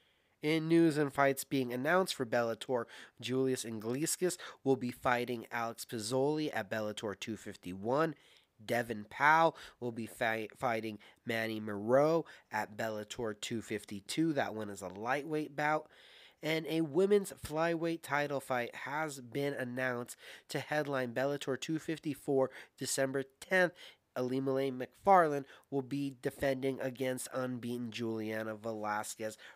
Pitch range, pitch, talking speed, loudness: 115-150 Hz, 130 Hz, 120 wpm, -35 LUFS